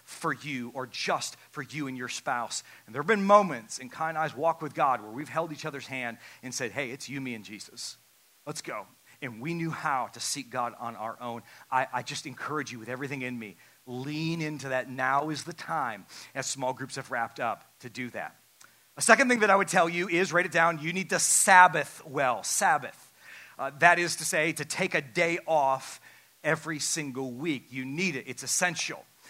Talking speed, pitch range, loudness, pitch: 220 wpm, 130-165 Hz, -28 LUFS, 145 Hz